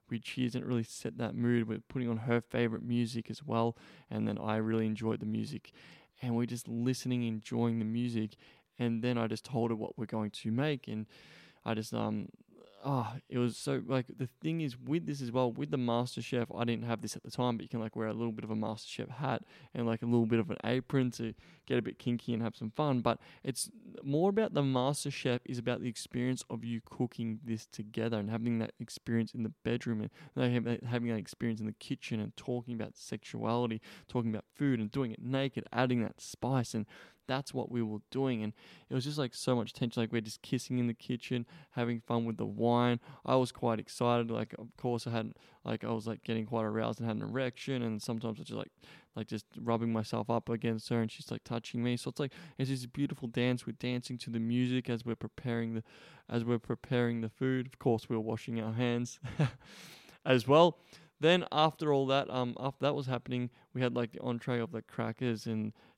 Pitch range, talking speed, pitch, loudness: 115-130 Hz, 230 wpm, 120 Hz, -35 LUFS